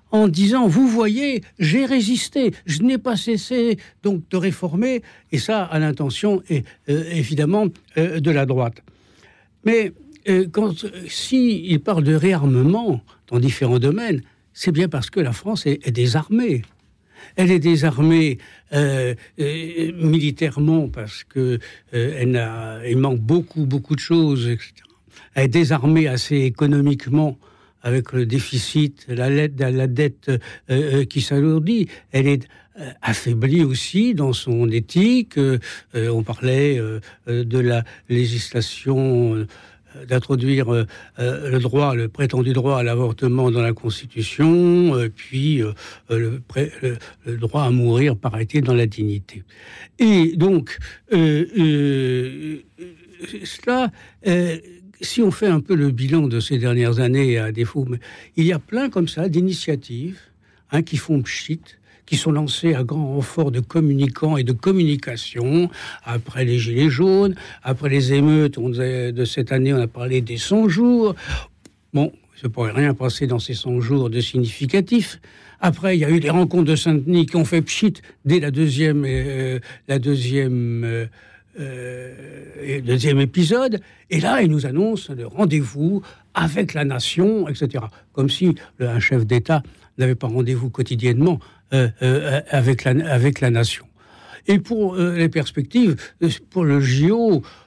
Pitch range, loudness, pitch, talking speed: 125-170 Hz, -19 LUFS, 140 Hz, 145 wpm